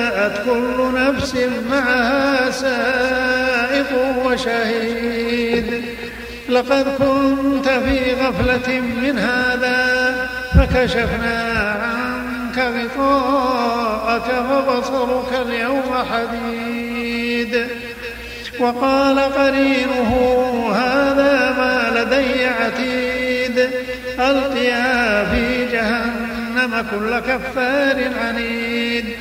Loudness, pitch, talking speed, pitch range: -18 LUFS, 250 Hz, 60 wpm, 235-255 Hz